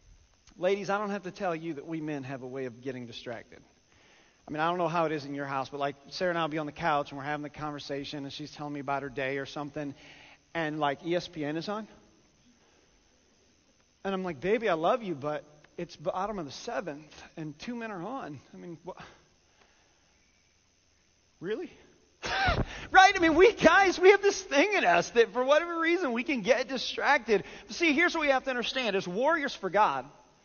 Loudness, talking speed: -28 LUFS, 215 wpm